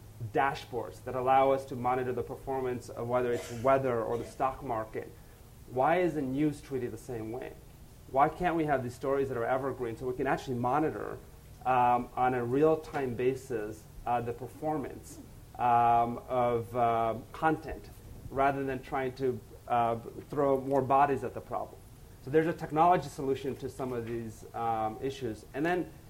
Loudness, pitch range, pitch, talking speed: -31 LUFS, 120-135 Hz, 125 Hz, 170 wpm